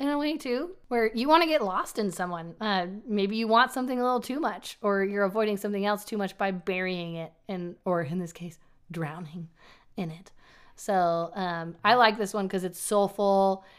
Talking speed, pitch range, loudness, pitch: 210 wpm, 175-220 Hz, -28 LUFS, 200 Hz